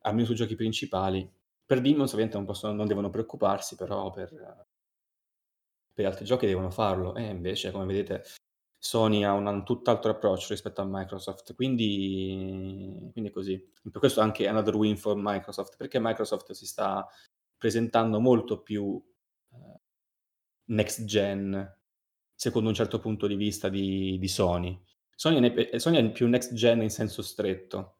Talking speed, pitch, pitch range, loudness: 150 wpm, 105 Hz, 95-115 Hz, -29 LUFS